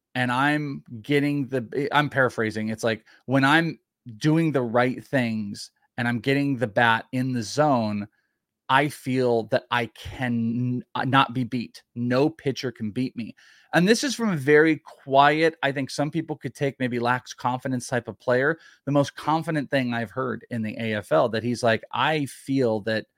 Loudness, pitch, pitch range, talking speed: -24 LUFS, 130 Hz, 120-145 Hz, 180 wpm